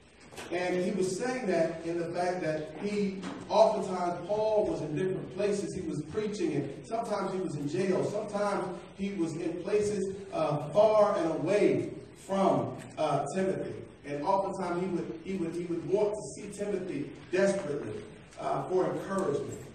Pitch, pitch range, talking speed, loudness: 190 Hz, 170-205 Hz, 160 wpm, -31 LUFS